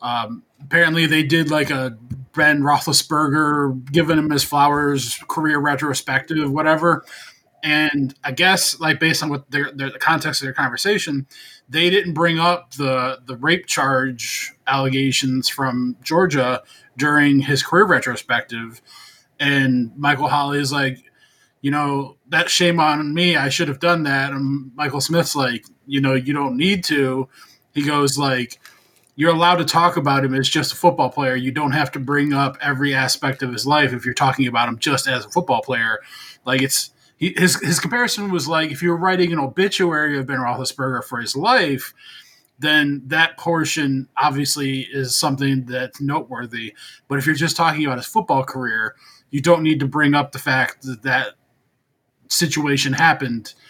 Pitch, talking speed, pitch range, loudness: 145 Hz, 170 wpm, 135-155 Hz, -18 LUFS